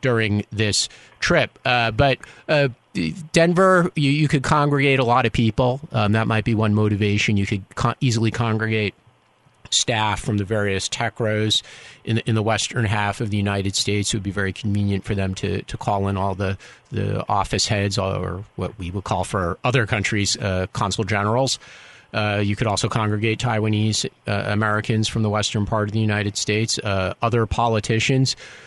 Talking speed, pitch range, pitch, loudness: 185 wpm, 100-120 Hz, 110 Hz, -21 LUFS